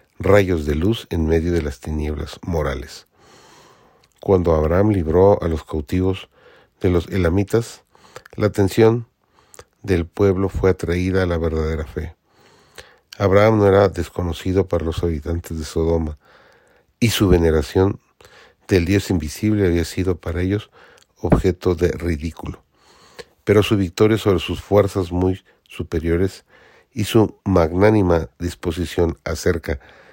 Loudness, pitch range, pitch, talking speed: -19 LUFS, 85-100 Hz, 90 Hz, 125 wpm